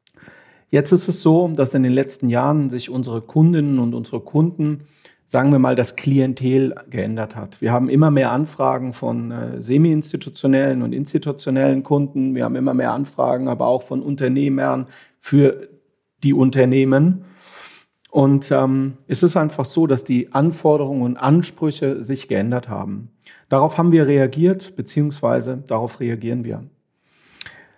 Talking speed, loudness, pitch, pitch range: 145 wpm, -18 LUFS, 135 Hz, 125-150 Hz